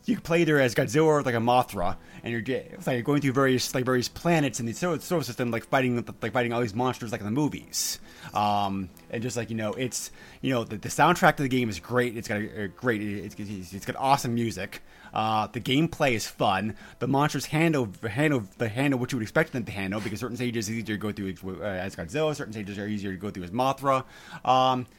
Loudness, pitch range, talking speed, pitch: -27 LUFS, 105-135 Hz, 245 wpm, 120 Hz